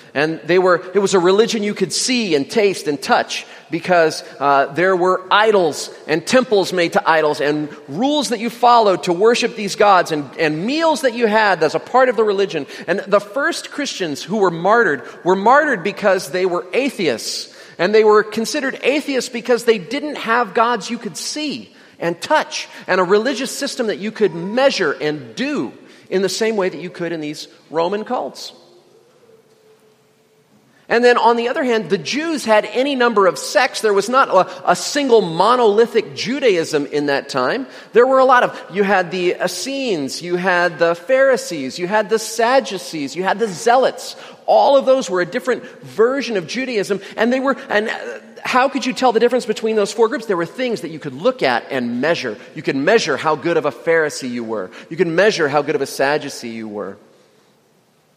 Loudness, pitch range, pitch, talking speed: -17 LUFS, 175-250 Hz, 210 Hz, 195 wpm